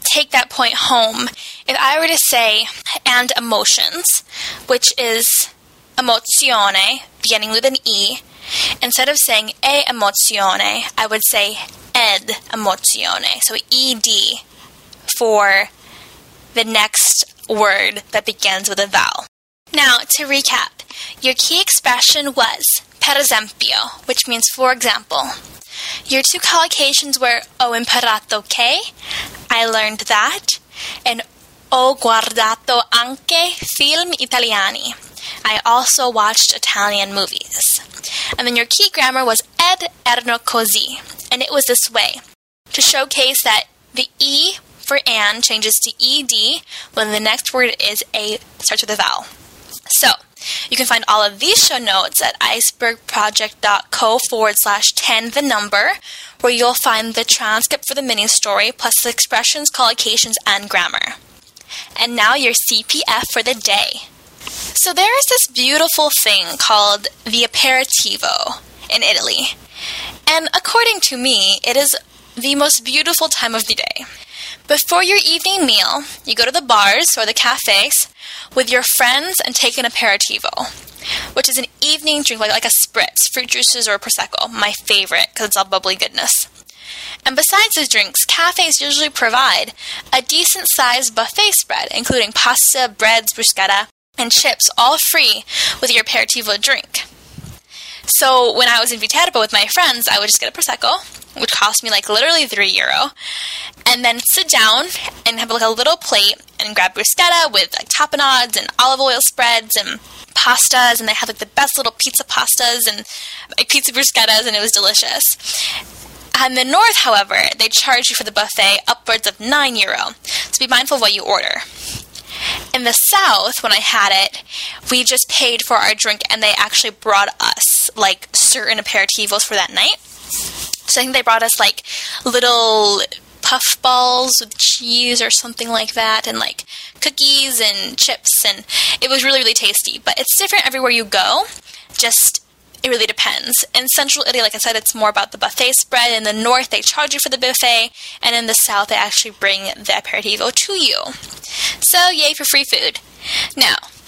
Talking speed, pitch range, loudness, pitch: 160 wpm, 220-275 Hz, -13 LUFS, 245 Hz